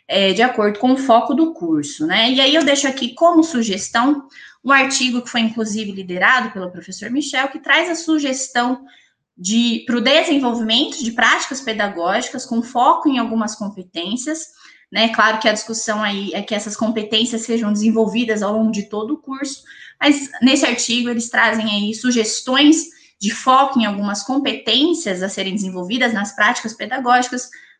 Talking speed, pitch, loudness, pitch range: 170 wpm, 240 Hz, -17 LUFS, 215-270 Hz